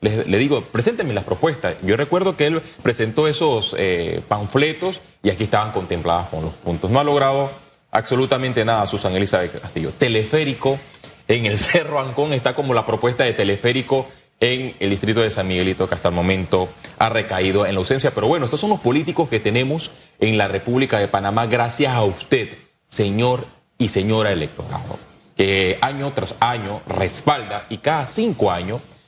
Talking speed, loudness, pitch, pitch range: 175 wpm, -20 LUFS, 115 Hz, 100-140 Hz